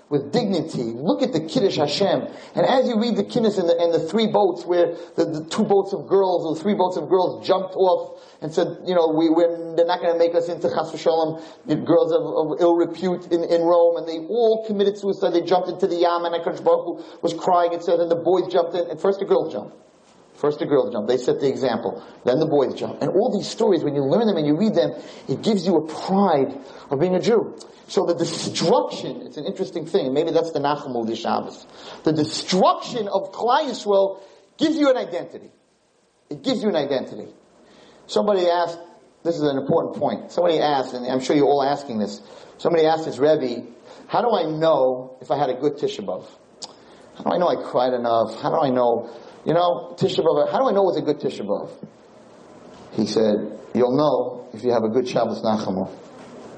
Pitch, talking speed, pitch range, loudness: 170 Hz, 215 wpm, 150-190 Hz, -21 LUFS